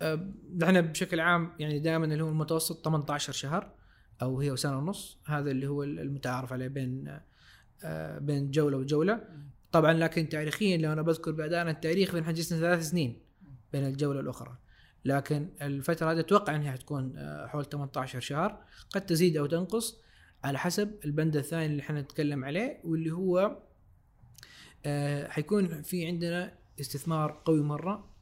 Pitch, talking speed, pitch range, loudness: 155 Hz, 140 wpm, 140-170 Hz, -31 LUFS